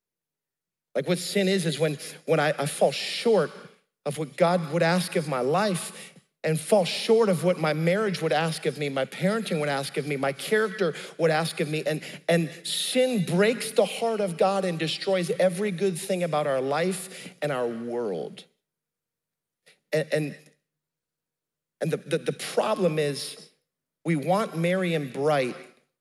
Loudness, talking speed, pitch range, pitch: -26 LUFS, 170 wpm, 150-190 Hz, 170 Hz